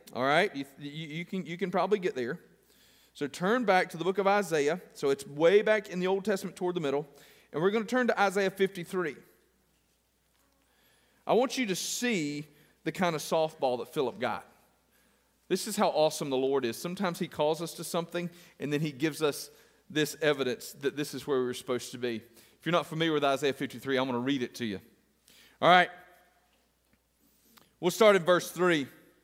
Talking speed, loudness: 205 wpm, -30 LUFS